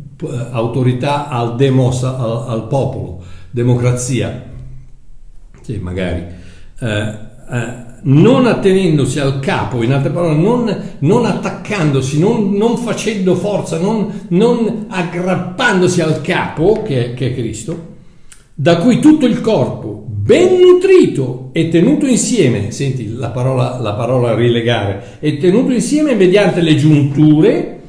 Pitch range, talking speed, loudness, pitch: 125-195 Hz, 125 wpm, -13 LUFS, 140 Hz